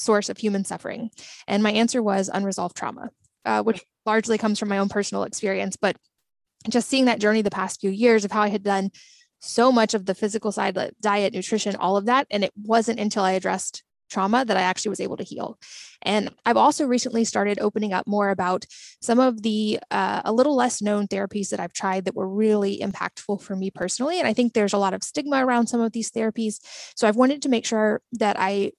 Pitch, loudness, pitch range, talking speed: 210 Hz, -23 LUFS, 195-230 Hz, 225 wpm